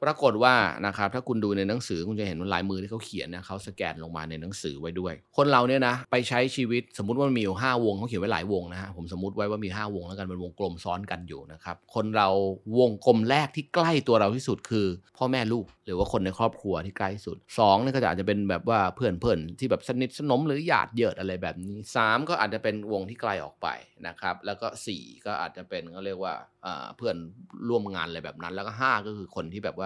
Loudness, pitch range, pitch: -28 LUFS, 95-120 Hz, 100 Hz